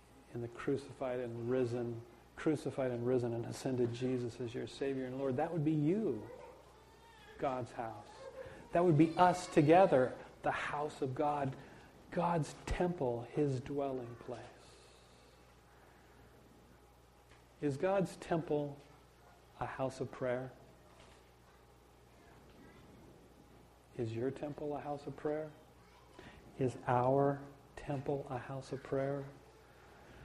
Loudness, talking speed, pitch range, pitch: -37 LUFS, 115 wpm, 120-150 Hz, 135 Hz